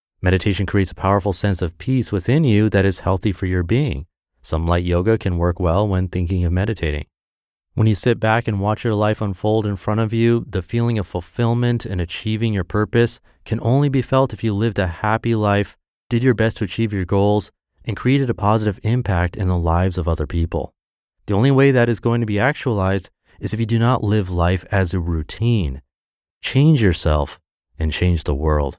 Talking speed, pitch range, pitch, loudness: 205 wpm, 90-115 Hz, 100 Hz, -19 LUFS